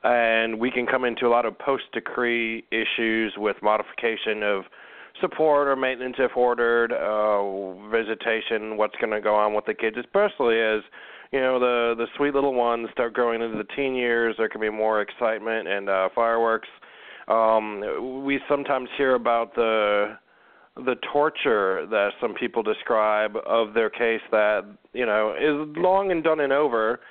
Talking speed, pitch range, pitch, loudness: 165 wpm, 110-125 Hz, 115 Hz, -24 LUFS